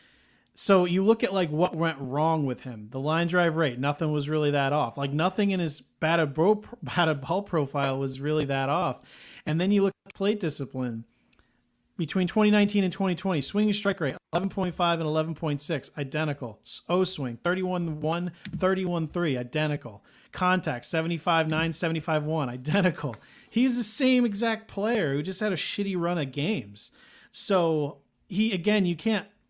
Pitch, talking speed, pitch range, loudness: 165 Hz, 165 wpm, 145-190 Hz, -27 LUFS